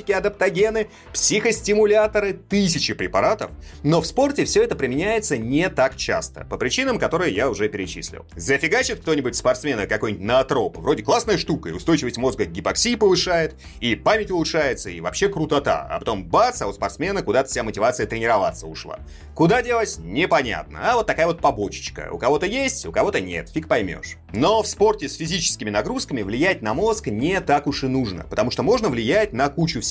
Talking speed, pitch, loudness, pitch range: 175 wpm, 180 Hz, -21 LUFS, 130-215 Hz